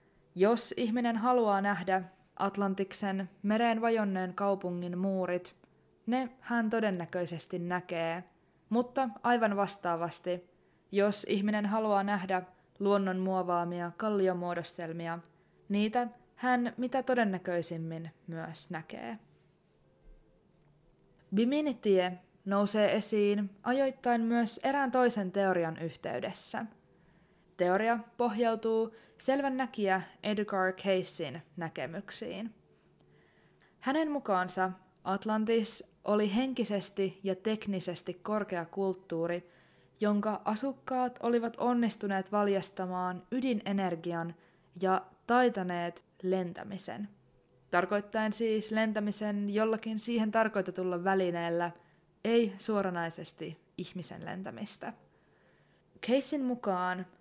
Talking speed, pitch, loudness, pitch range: 80 wpm, 195 Hz, -32 LUFS, 180-220 Hz